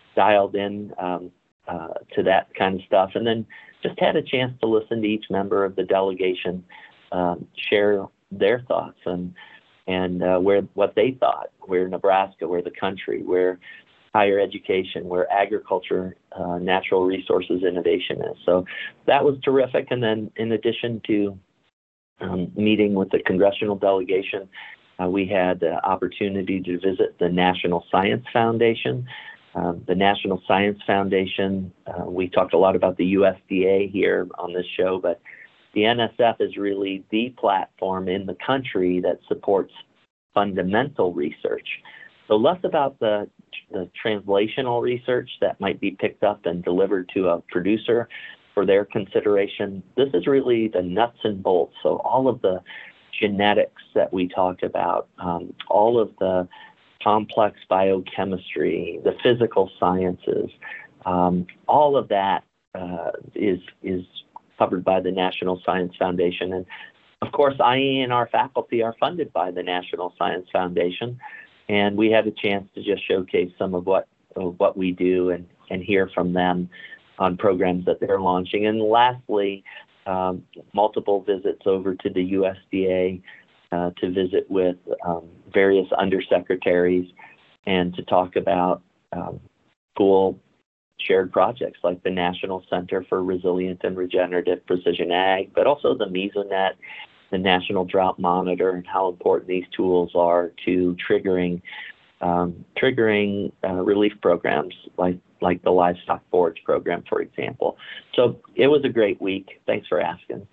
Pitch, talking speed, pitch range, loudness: 95 Hz, 150 wpm, 90-105 Hz, -22 LUFS